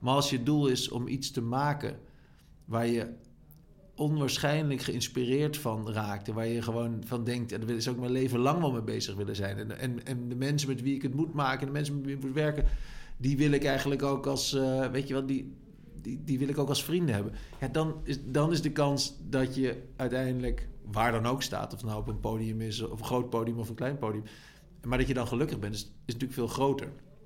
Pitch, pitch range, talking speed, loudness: 130 Hz, 115-140 Hz, 215 wpm, -31 LUFS